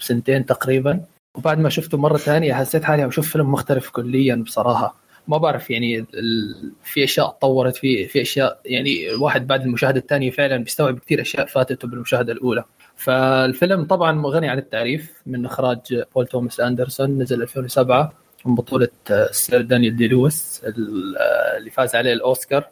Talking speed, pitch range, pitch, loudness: 150 wpm, 125-150 Hz, 130 Hz, -19 LUFS